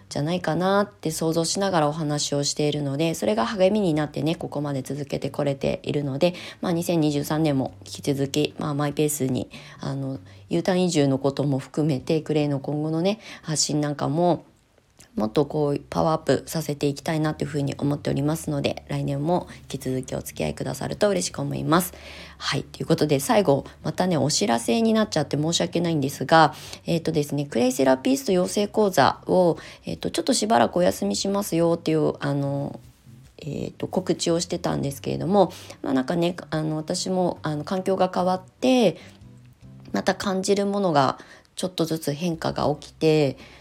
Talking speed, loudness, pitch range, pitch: 390 characters per minute, -24 LUFS, 140-175 Hz, 150 Hz